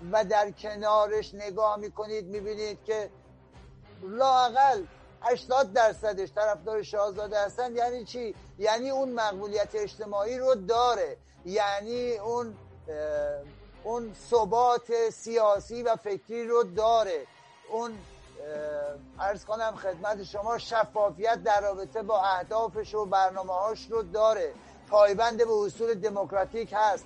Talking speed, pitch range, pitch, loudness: 110 wpm, 200-235 Hz, 215 Hz, -28 LUFS